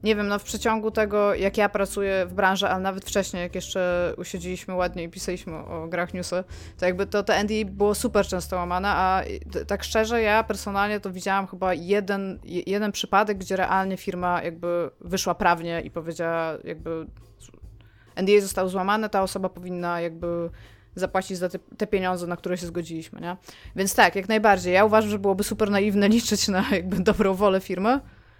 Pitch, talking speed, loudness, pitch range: 190 Hz, 180 wpm, -24 LUFS, 175-205 Hz